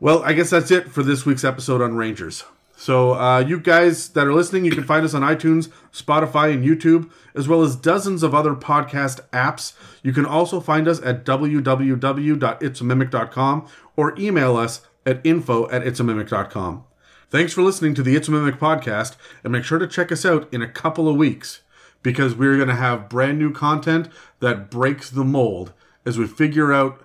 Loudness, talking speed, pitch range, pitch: -19 LUFS, 190 wpm, 125-160 Hz, 145 Hz